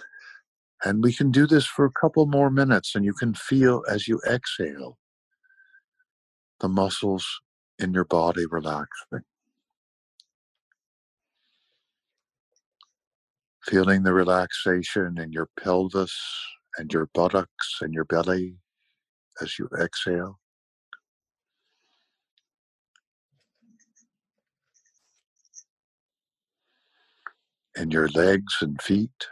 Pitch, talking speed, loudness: 100 Hz, 90 wpm, -24 LUFS